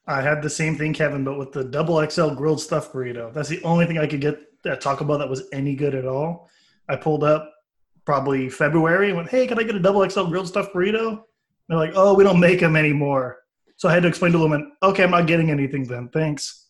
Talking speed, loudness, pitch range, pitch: 250 wpm, -21 LUFS, 145-175 Hz, 155 Hz